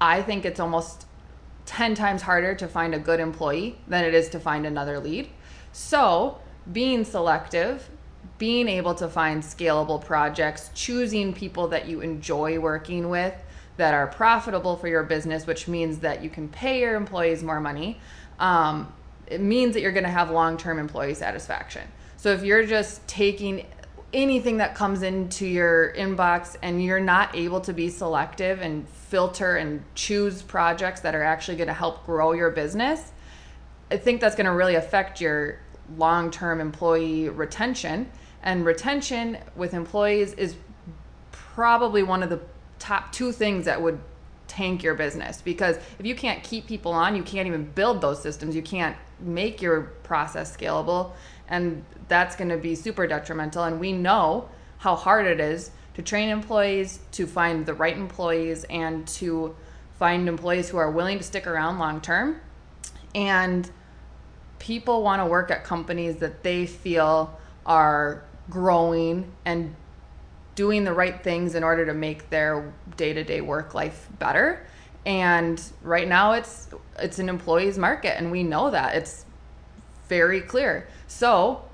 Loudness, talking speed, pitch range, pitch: -24 LUFS, 160 wpm, 160-190 Hz, 170 Hz